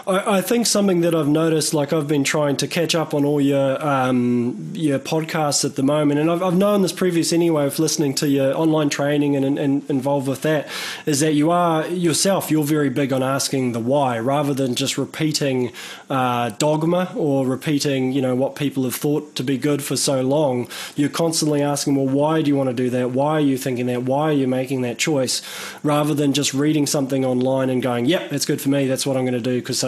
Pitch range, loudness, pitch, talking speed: 135-155 Hz, -20 LUFS, 145 Hz, 230 wpm